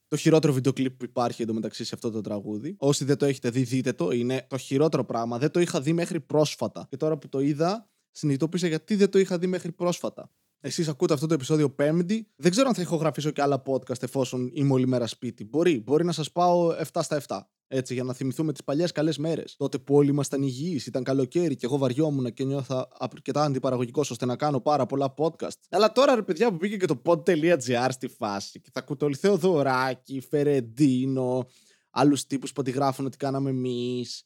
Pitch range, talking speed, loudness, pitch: 130-160 Hz, 210 wpm, -26 LUFS, 140 Hz